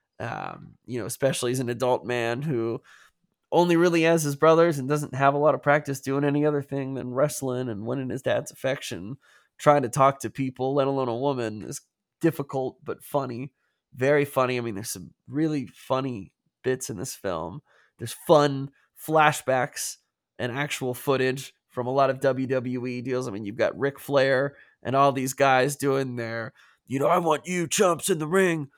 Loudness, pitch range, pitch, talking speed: -25 LUFS, 125-145 Hz, 135 Hz, 190 wpm